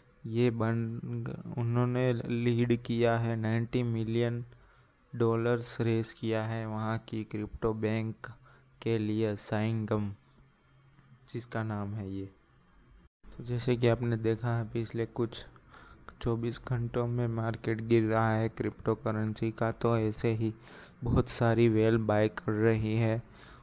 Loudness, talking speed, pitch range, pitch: -31 LUFS, 130 wpm, 110-120 Hz, 115 Hz